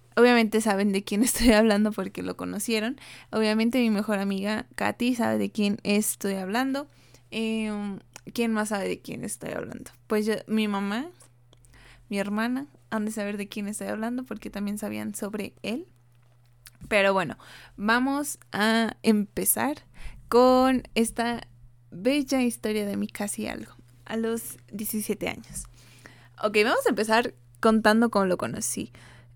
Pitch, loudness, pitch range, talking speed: 210 Hz, -26 LUFS, 190-225 Hz, 145 wpm